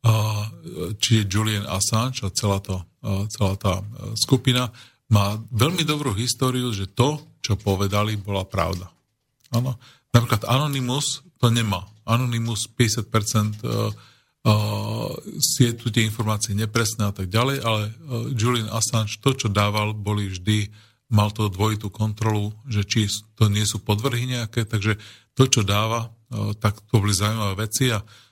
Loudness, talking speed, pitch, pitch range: -23 LUFS, 150 wpm, 110 Hz, 105-120 Hz